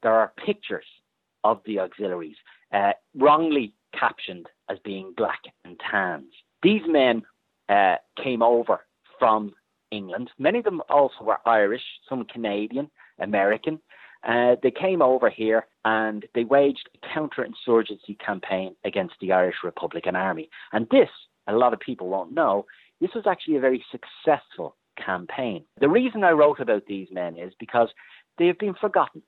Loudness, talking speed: -24 LUFS, 150 wpm